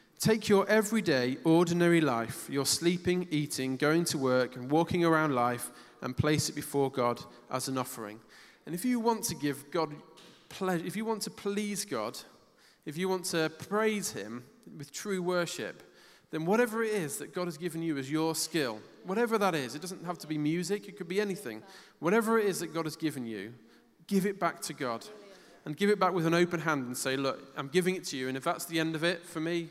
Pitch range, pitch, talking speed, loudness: 145-185 Hz, 165 Hz, 220 wpm, -31 LUFS